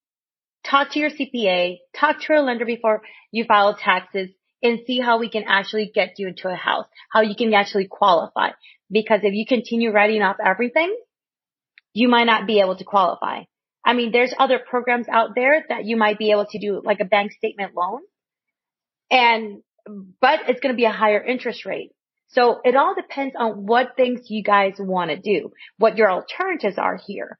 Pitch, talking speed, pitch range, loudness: 225 Hz, 195 wpm, 205-250 Hz, -20 LUFS